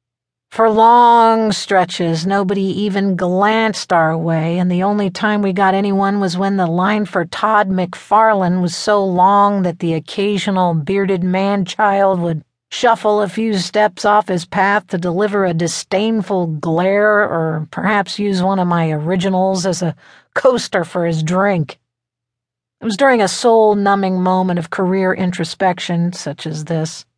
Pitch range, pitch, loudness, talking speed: 170-205 Hz, 190 Hz, -15 LUFS, 155 wpm